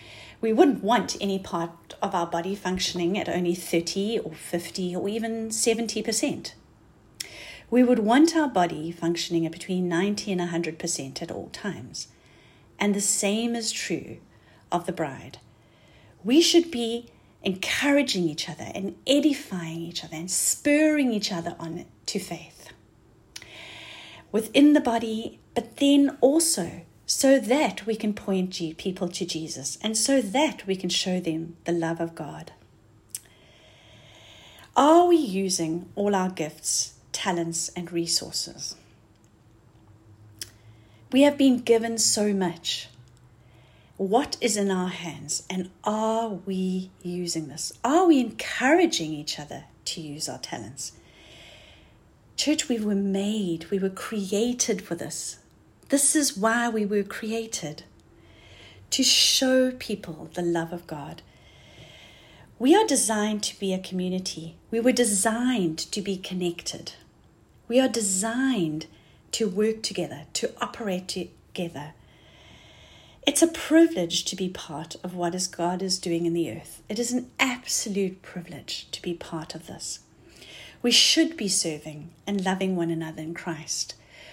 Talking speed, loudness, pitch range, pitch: 135 wpm, -25 LUFS, 160-225 Hz, 185 Hz